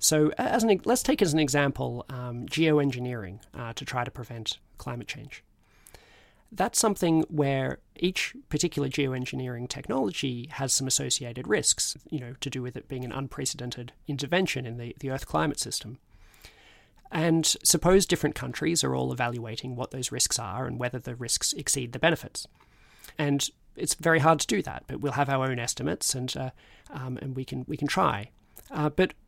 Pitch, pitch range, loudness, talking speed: 130 Hz, 120-150 Hz, -28 LUFS, 175 wpm